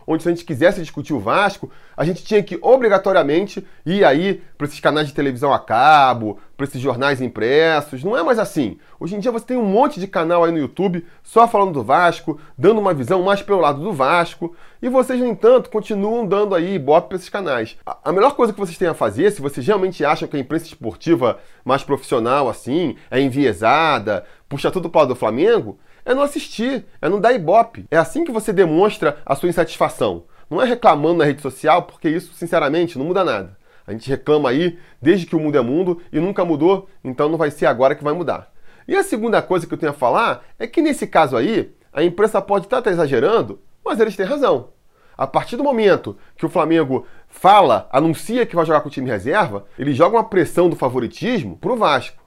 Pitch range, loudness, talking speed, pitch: 150-205 Hz, -18 LUFS, 215 wpm, 175 Hz